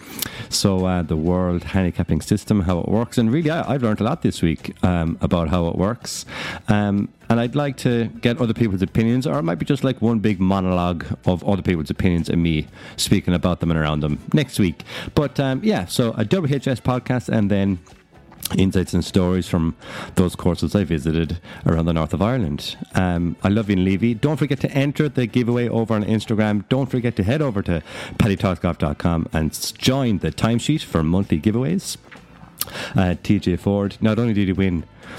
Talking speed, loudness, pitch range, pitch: 195 wpm, -21 LUFS, 90-120 Hz, 100 Hz